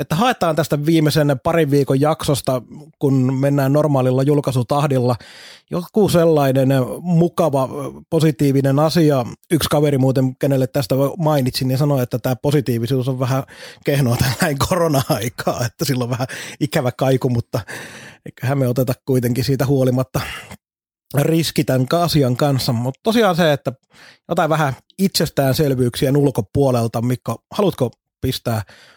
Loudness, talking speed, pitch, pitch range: -18 LUFS, 125 wpm, 140 Hz, 130-155 Hz